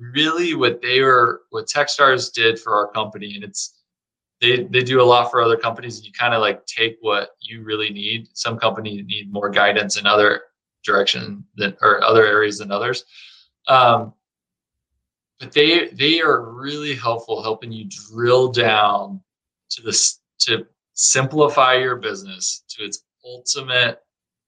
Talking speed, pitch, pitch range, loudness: 155 wpm, 115 Hz, 105-130 Hz, -17 LUFS